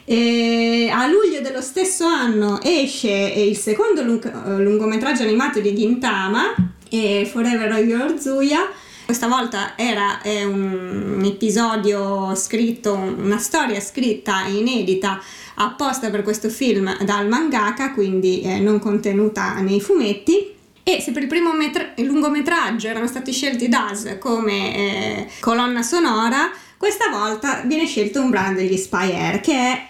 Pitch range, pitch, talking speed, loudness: 205-270 Hz, 225 Hz, 135 wpm, -19 LUFS